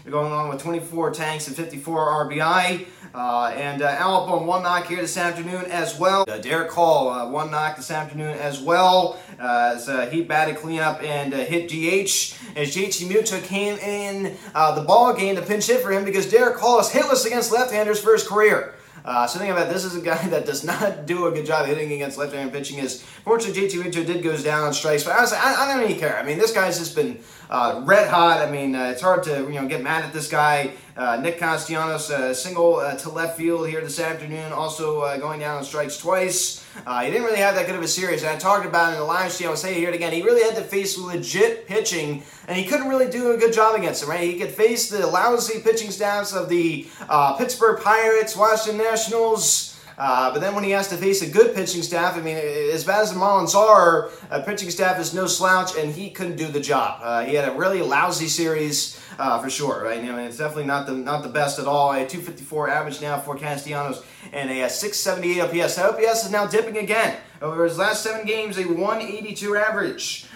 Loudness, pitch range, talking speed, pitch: -21 LUFS, 150-200 Hz, 235 wpm, 170 Hz